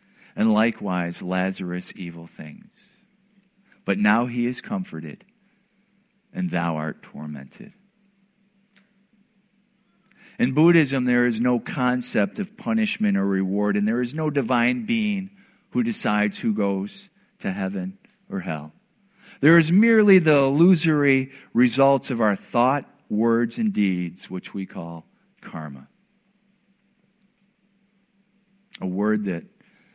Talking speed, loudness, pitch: 115 wpm, -22 LUFS, 170 Hz